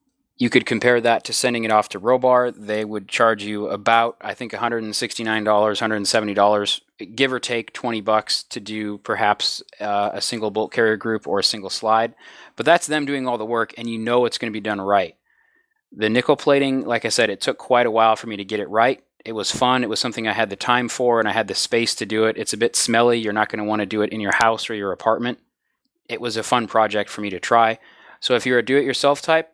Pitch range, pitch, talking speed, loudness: 110-125 Hz, 115 Hz, 250 wpm, -20 LUFS